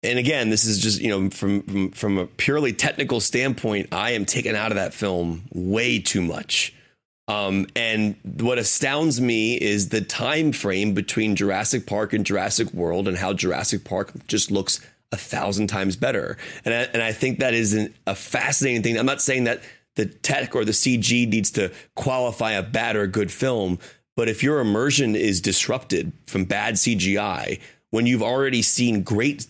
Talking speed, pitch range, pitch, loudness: 185 wpm, 100-125 Hz, 110 Hz, -21 LUFS